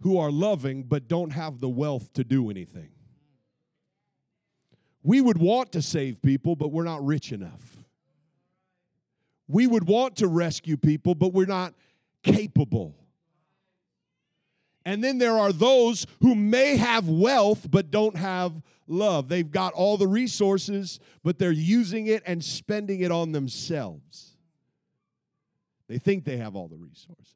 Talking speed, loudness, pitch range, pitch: 145 wpm, -24 LUFS, 150-200 Hz, 170 Hz